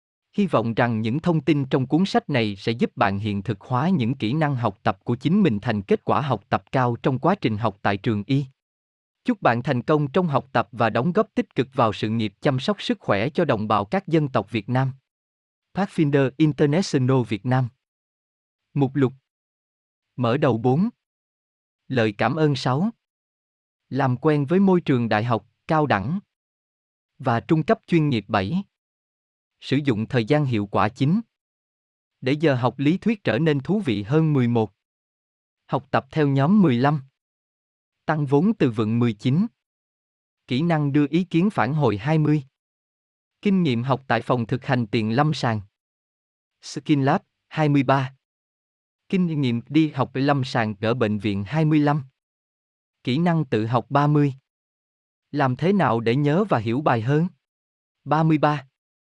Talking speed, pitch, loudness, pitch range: 170 wpm, 135 Hz, -22 LUFS, 115-155 Hz